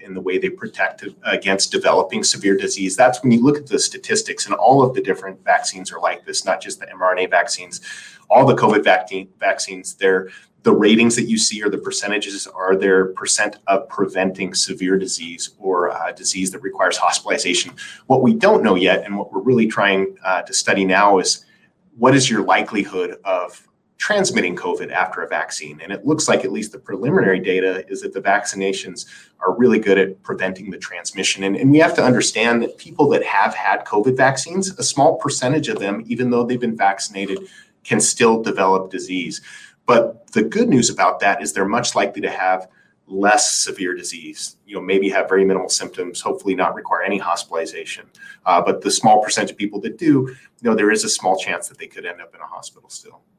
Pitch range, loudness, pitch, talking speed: 95-130 Hz, -18 LUFS, 100 Hz, 205 wpm